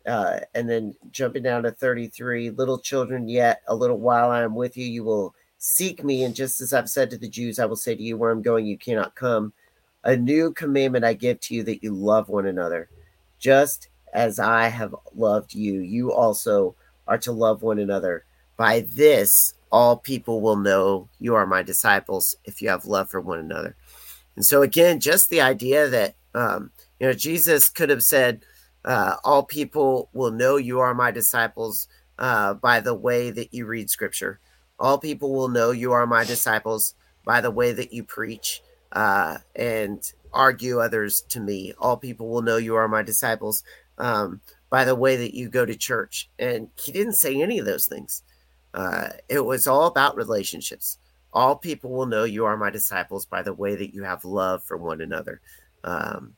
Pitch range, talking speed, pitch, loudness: 105-130 Hz, 195 wpm, 120 Hz, -22 LUFS